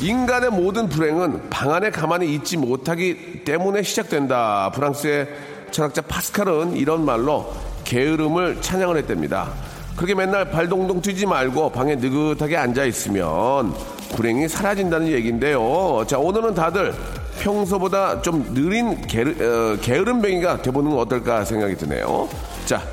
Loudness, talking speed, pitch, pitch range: -21 LUFS, 320 characters per minute, 160 Hz, 130-190 Hz